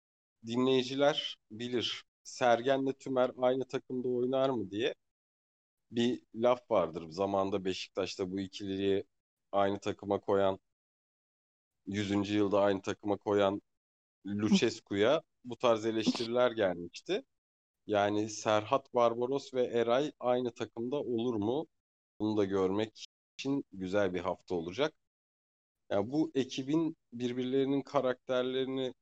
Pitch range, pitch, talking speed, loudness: 100-125 Hz, 110 Hz, 110 wpm, -33 LUFS